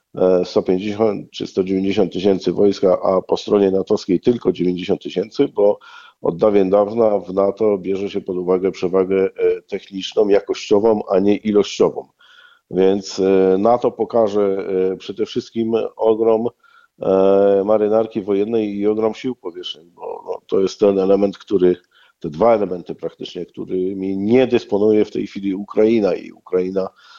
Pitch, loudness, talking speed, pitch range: 105 Hz, -18 LUFS, 130 wpm, 95-115 Hz